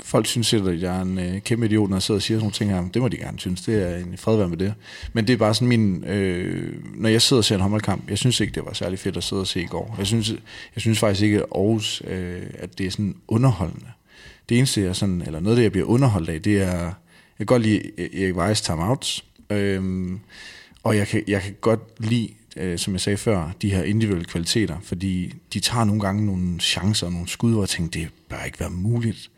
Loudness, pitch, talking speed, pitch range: -22 LUFS, 100 Hz, 260 wpm, 95-110 Hz